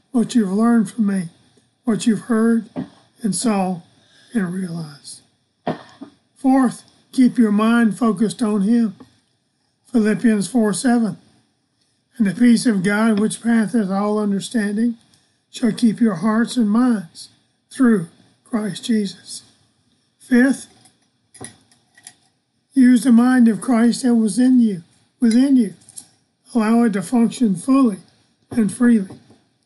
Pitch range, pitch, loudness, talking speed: 195-235 Hz, 225 Hz, -18 LUFS, 120 wpm